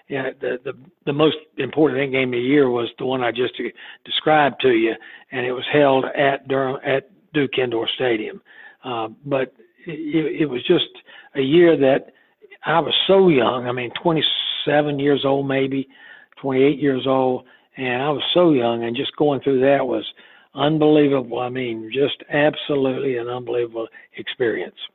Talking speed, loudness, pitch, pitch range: 165 wpm, -20 LUFS, 140 Hz, 130-155 Hz